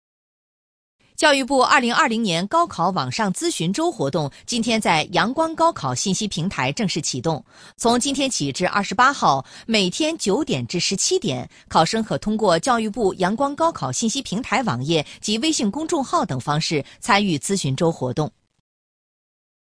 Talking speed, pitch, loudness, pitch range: 220 characters per minute, 200 Hz, -20 LUFS, 165-245 Hz